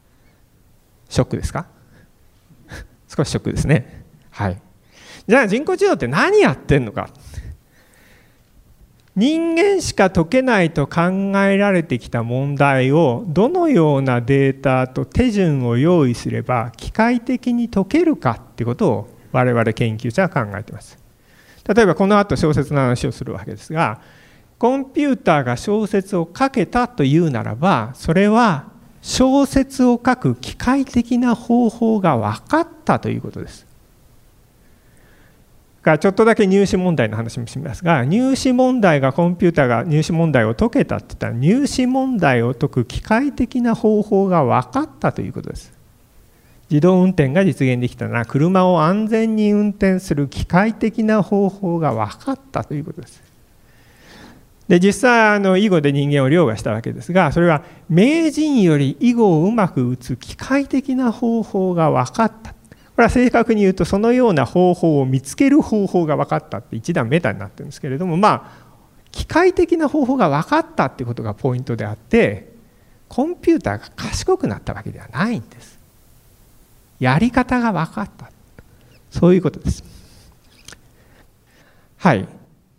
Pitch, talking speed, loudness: 180 Hz, 310 characters per minute, -17 LUFS